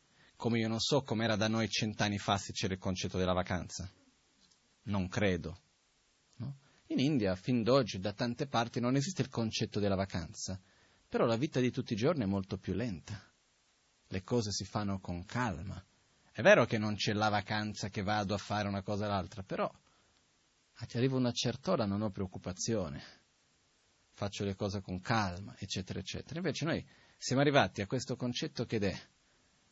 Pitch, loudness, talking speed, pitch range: 105 Hz, -34 LUFS, 180 wpm, 100-120 Hz